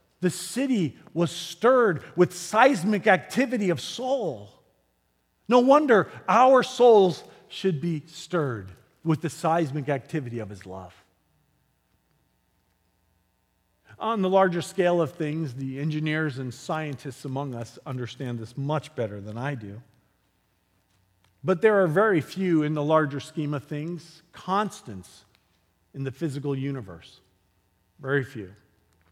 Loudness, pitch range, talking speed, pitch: -25 LUFS, 110-180 Hz, 125 wpm, 150 Hz